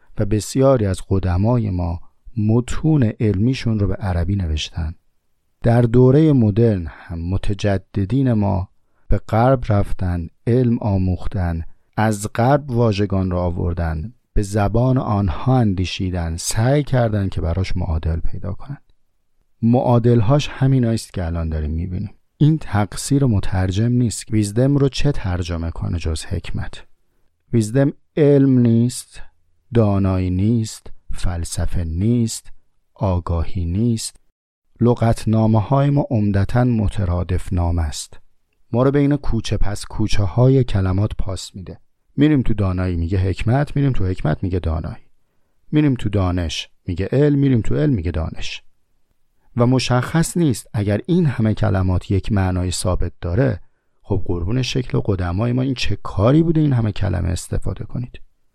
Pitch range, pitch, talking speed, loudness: 90-120 Hz, 105 Hz, 130 wpm, -19 LUFS